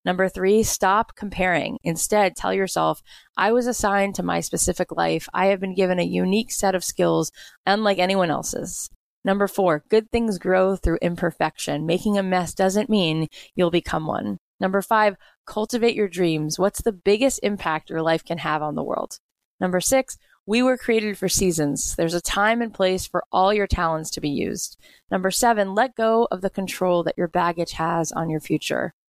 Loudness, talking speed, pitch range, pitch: -22 LUFS, 185 wpm, 165-205 Hz, 185 Hz